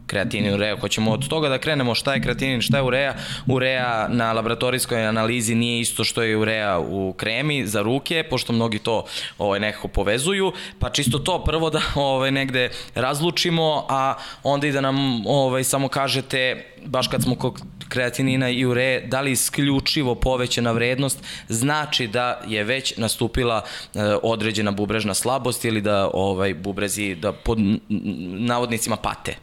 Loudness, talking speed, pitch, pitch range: -22 LUFS, 155 wpm, 125 Hz, 110-135 Hz